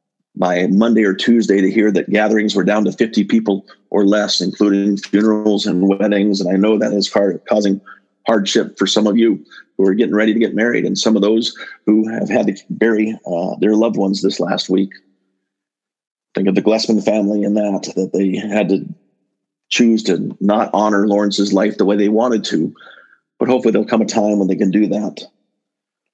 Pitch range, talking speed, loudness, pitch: 95-110 Hz, 200 wpm, -16 LUFS, 105 Hz